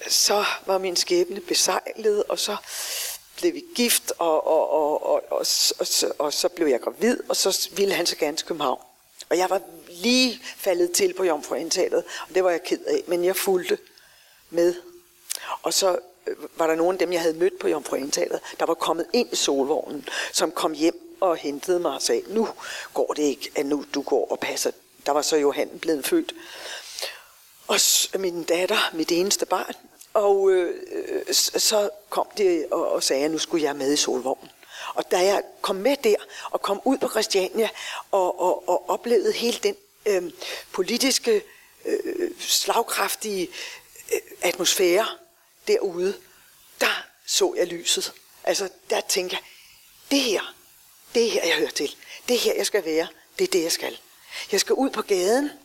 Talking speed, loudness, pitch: 180 wpm, -23 LUFS, 345 Hz